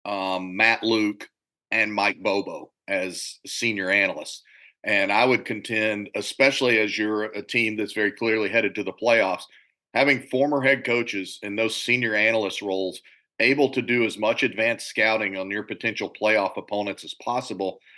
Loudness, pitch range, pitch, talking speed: -23 LUFS, 105-120 Hz, 110 Hz, 160 wpm